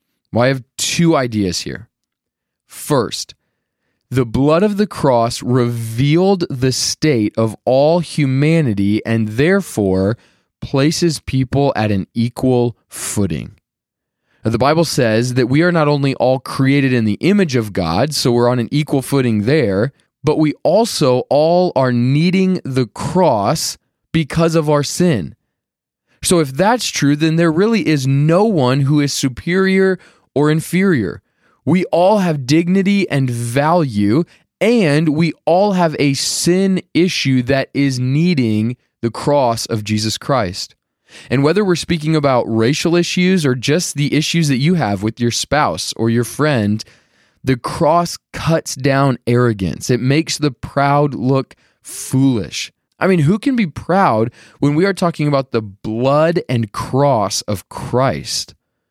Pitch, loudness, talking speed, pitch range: 140 Hz, -16 LUFS, 150 wpm, 120-165 Hz